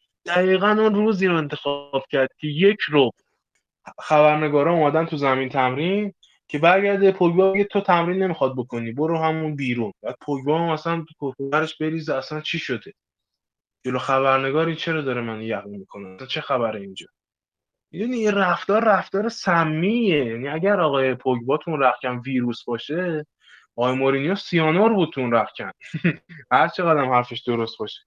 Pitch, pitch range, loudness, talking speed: 155 Hz, 130-175 Hz, -21 LUFS, 145 wpm